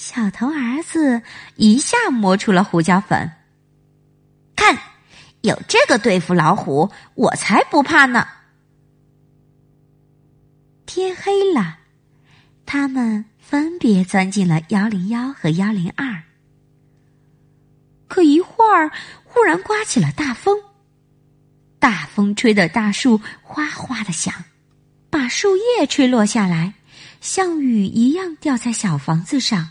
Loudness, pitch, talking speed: -17 LUFS, 195 Hz, 160 characters per minute